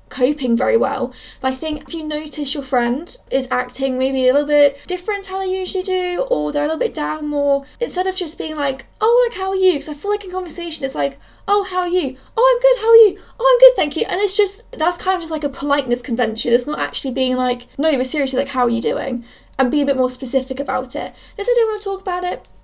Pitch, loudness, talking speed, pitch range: 300 Hz, -18 LUFS, 275 wpm, 260-375 Hz